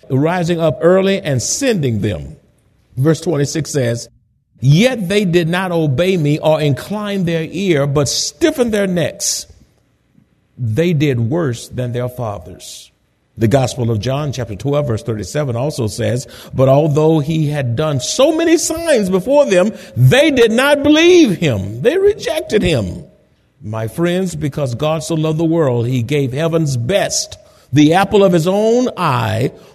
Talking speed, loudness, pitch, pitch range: 150 wpm, -15 LUFS, 155 Hz, 125-190 Hz